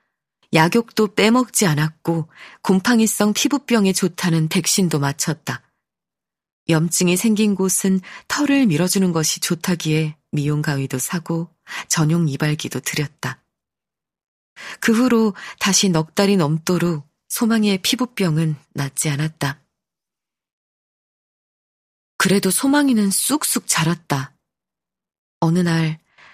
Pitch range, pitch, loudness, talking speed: 155-210 Hz, 175 Hz, -19 LUFS, 230 characters per minute